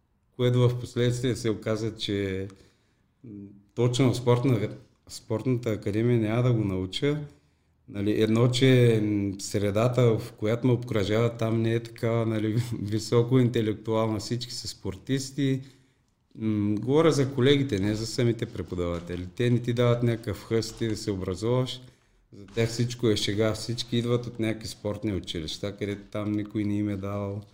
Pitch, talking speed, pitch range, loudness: 110 Hz, 150 wpm, 105-120 Hz, -27 LUFS